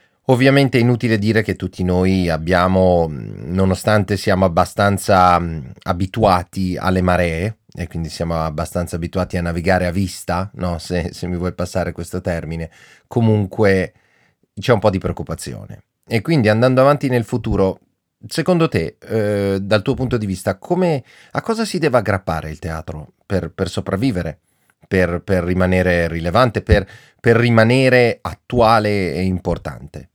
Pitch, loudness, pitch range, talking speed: 95 Hz, -18 LUFS, 90-110 Hz, 145 wpm